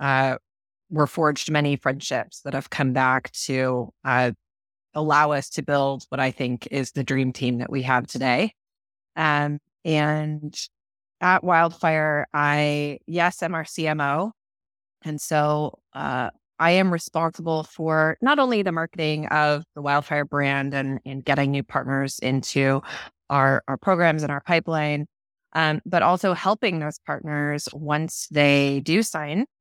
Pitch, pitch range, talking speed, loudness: 150 Hz, 135-160 Hz, 145 wpm, -23 LUFS